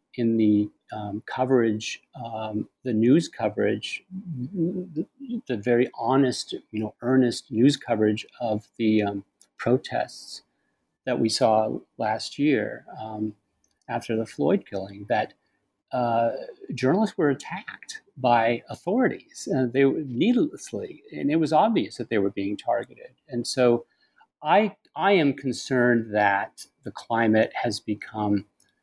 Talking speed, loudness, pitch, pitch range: 130 wpm, -25 LUFS, 115 Hz, 110-135 Hz